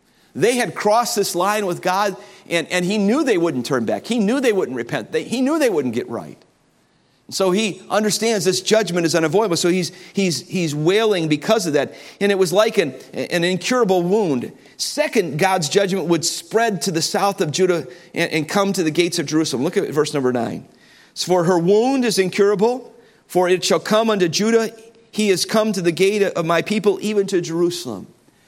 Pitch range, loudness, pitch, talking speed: 175-215 Hz, -19 LUFS, 190 Hz, 205 wpm